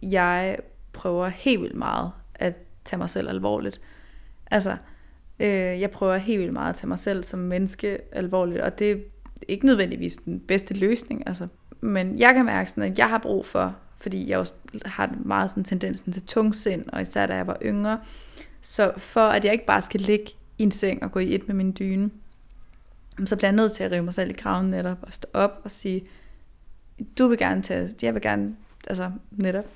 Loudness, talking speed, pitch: -25 LUFS, 210 wpm, 190 Hz